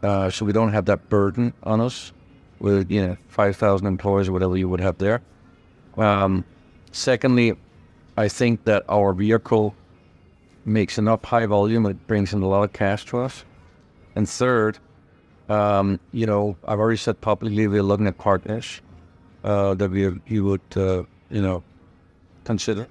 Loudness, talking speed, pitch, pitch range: -22 LUFS, 165 wpm, 100 Hz, 95-110 Hz